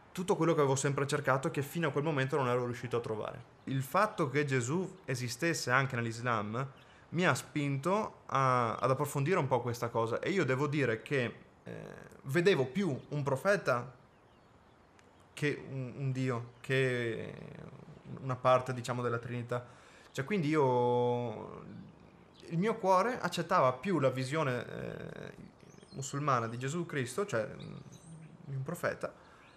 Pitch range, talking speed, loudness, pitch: 125-160 Hz, 145 wpm, -33 LUFS, 135 Hz